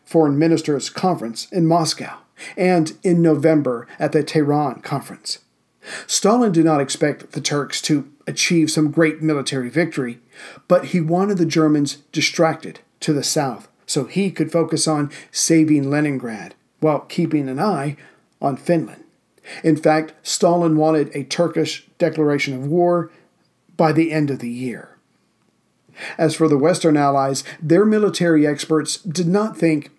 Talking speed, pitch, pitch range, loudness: 145 wpm, 155 Hz, 145-170 Hz, -19 LUFS